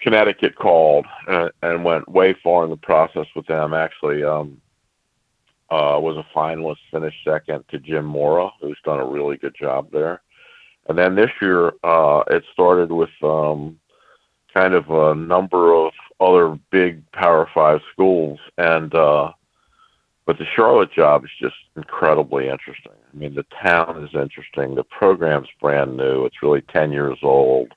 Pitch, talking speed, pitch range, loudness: 80 Hz, 160 wpm, 75-85 Hz, -18 LUFS